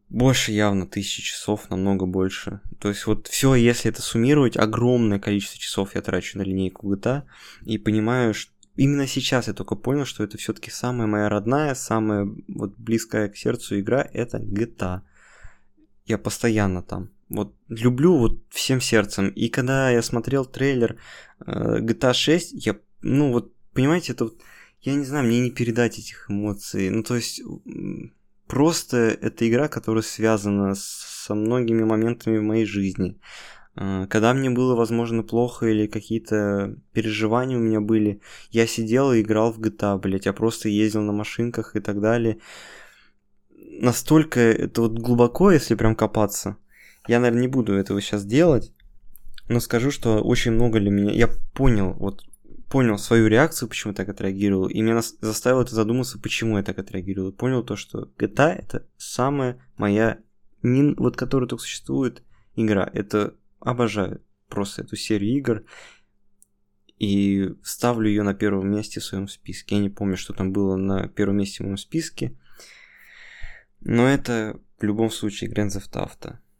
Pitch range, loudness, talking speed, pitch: 100-120 Hz, -23 LUFS, 155 wpm, 110 Hz